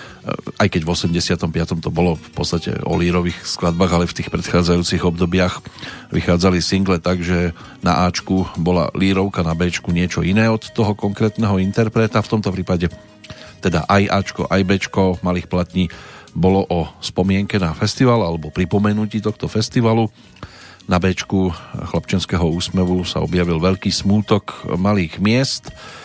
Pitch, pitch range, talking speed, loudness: 90 Hz, 85-105 Hz, 140 wpm, -18 LUFS